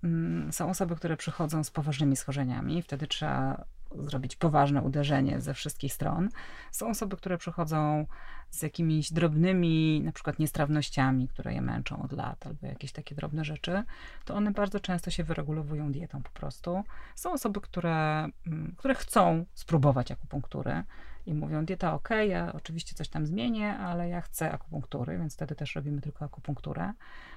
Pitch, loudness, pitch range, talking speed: 155 Hz, -31 LUFS, 145-175 Hz, 155 wpm